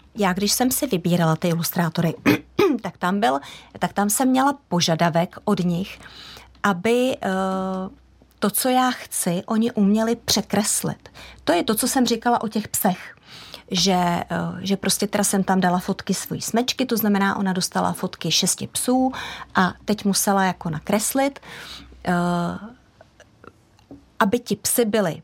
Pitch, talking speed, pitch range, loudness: 200 Hz, 145 wpm, 180-235 Hz, -21 LUFS